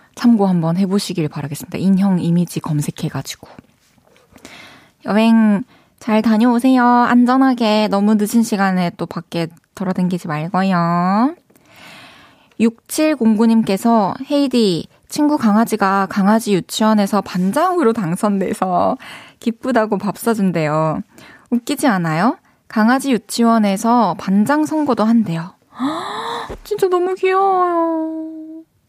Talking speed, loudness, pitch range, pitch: 255 characters per minute, -16 LUFS, 185-250 Hz, 215 Hz